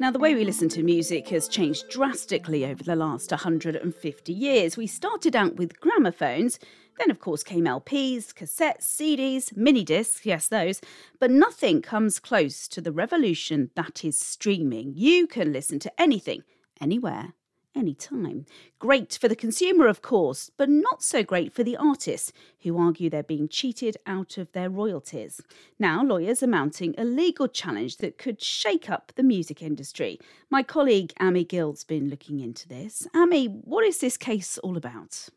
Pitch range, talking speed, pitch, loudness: 165-275 Hz, 170 wpm, 215 Hz, -25 LUFS